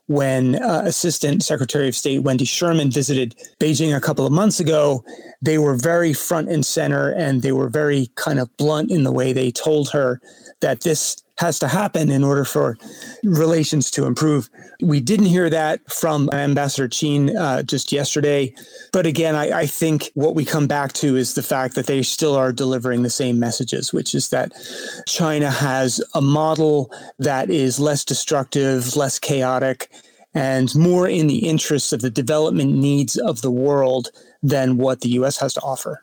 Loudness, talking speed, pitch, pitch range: -19 LUFS, 180 wpm, 145 Hz, 130-155 Hz